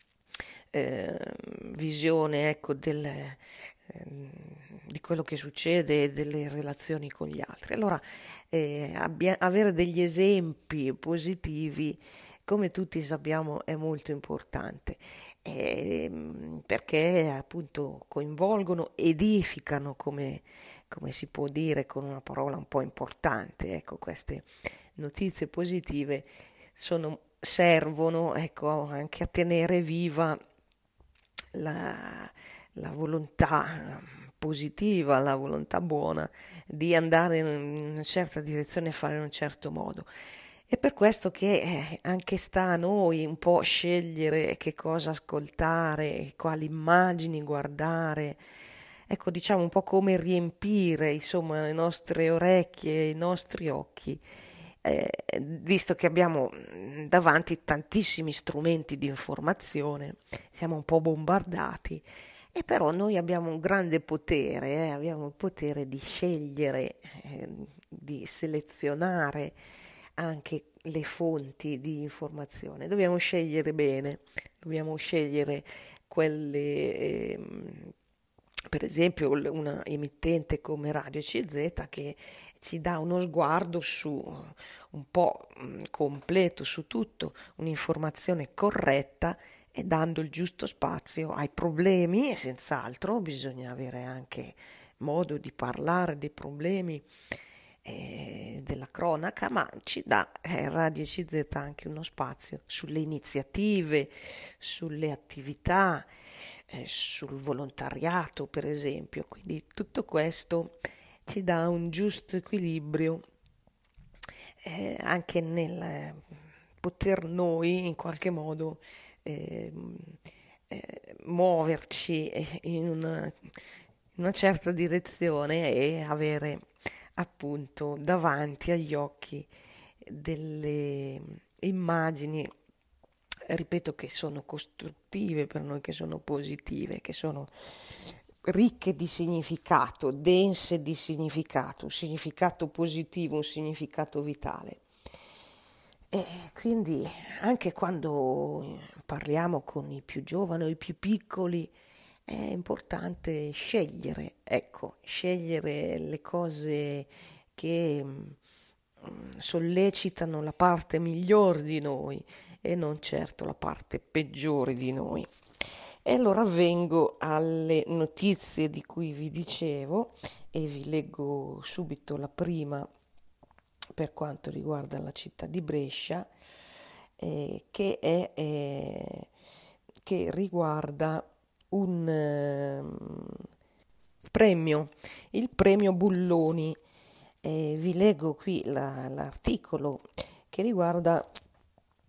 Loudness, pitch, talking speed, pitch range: -30 LUFS, 160 Hz, 105 wpm, 145-175 Hz